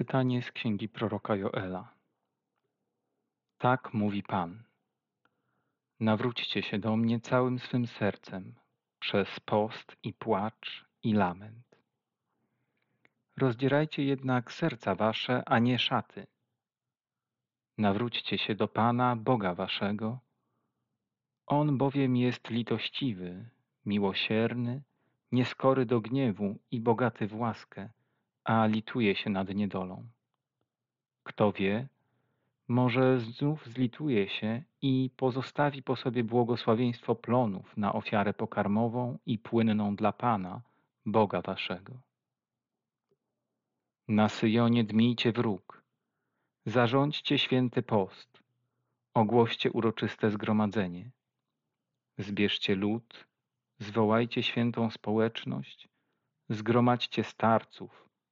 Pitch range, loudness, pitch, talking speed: 110-125 Hz, -30 LUFS, 120 Hz, 90 wpm